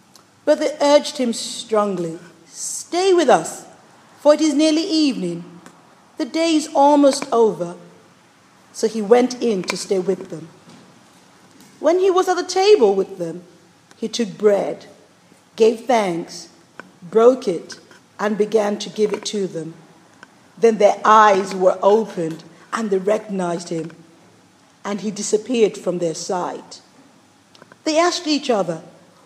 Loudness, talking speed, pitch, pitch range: -18 LUFS, 135 wpm, 210 Hz, 175-255 Hz